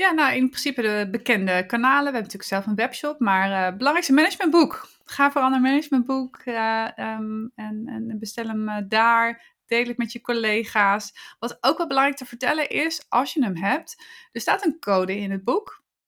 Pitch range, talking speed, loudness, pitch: 215-280 Hz, 200 wpm, -22 LUFS, 240 Hz